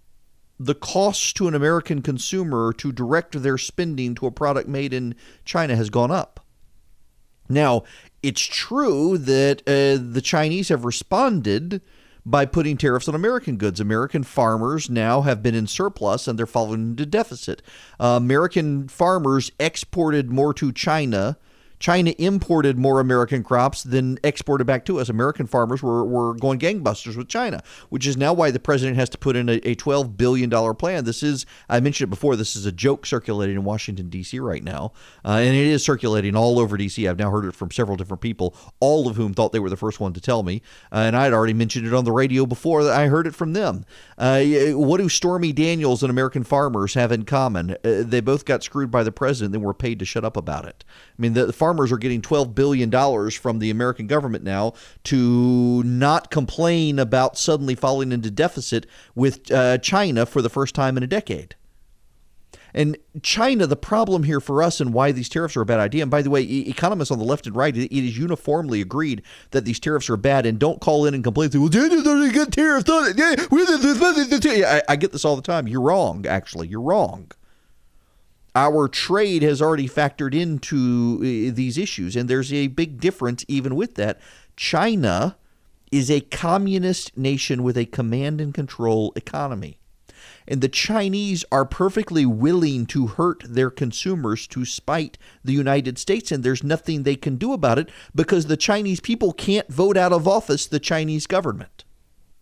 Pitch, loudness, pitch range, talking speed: 135 Hz, -21 LUFS, 120-155 Hz, 190 wpm